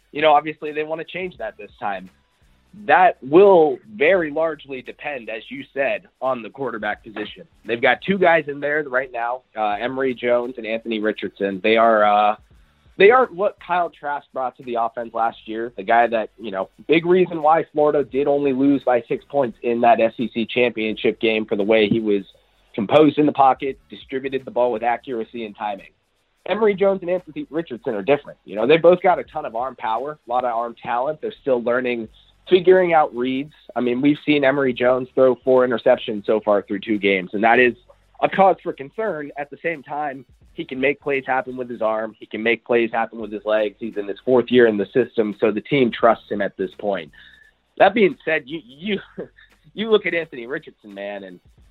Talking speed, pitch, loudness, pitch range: 215 wpm, 125 Hz, -20 LUFS, 115-150 Hz